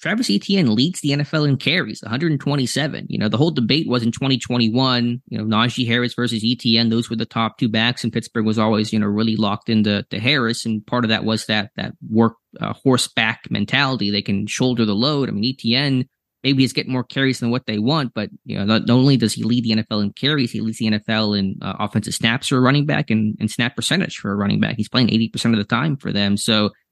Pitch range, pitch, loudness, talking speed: 110-130 Hz, 115 Hz, -19 LUFS, 245 wpm